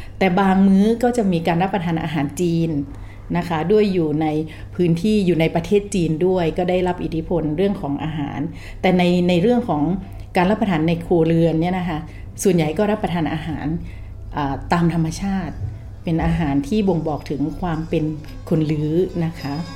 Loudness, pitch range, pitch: -20 LUFS, 155-185 Hz, 165 Hz